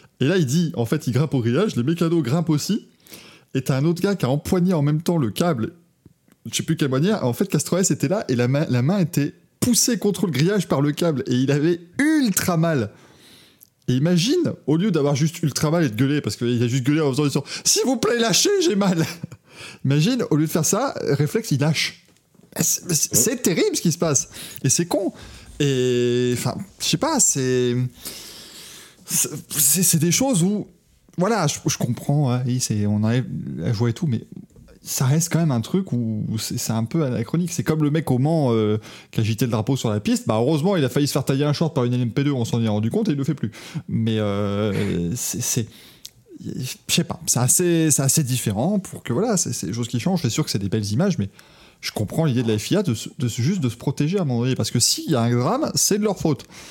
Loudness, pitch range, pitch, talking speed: -21 LUFS, 125-170 Hz, 145 Hz, 245 wpm